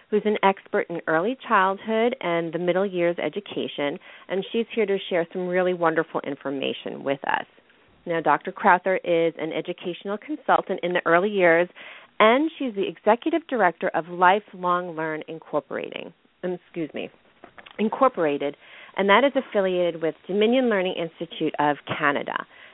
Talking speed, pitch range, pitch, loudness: 150 wpm, 165-210 Hz, 180 Hz, -24 LUFS